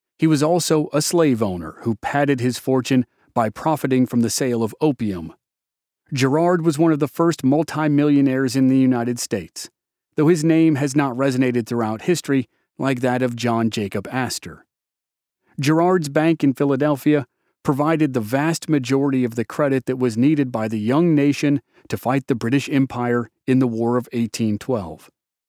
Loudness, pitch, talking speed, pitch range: -20 LUFS, 135 Hz, 165 wpm, 120-150 Hz